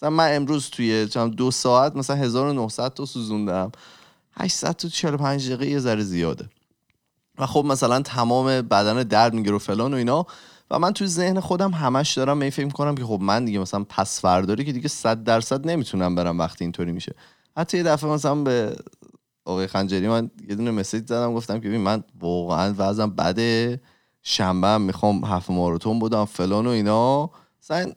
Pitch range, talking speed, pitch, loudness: 100-140 Hz, 165 wpm, 115 Hz, -22 LUFS